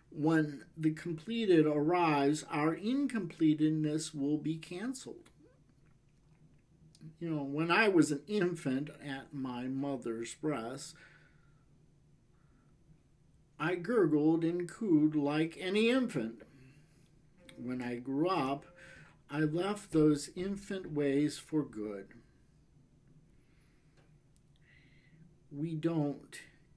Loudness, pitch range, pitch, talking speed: -33 LUFS, 145-160 Hz, 150 Hz, 90 wpm